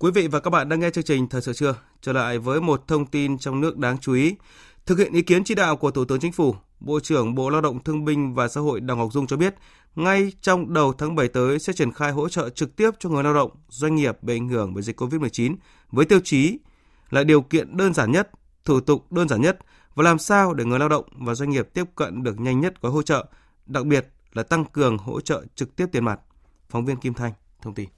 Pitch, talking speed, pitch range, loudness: 145 Hz, 265 wpm, 125-160 Hz, -22 LUFS